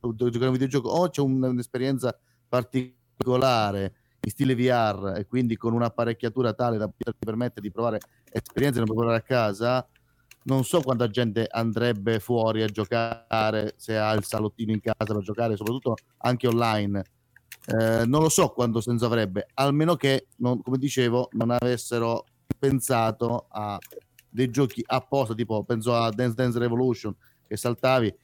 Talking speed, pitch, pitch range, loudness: 150 wpm, 120 Hz, 110-125 Hz, -26 LUFS